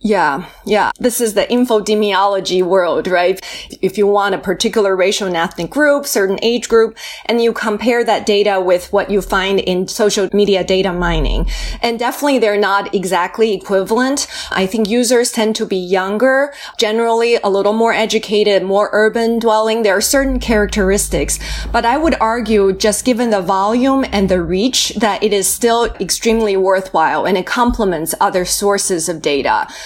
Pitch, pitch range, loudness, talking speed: 210 Hz, 195-230 Hz, -14 LUFS, 165 wpm